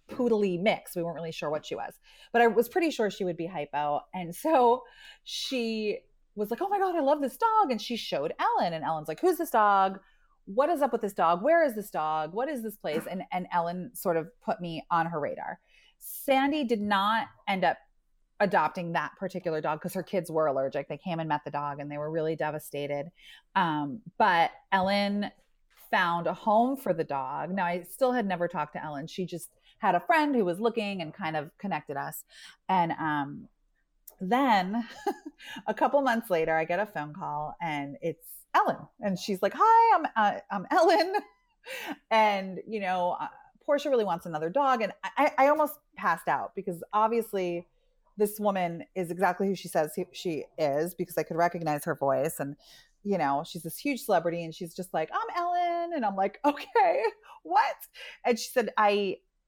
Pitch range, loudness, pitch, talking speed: 165-255 Hz, -29 LUFS, 195 Hz, 200 wpm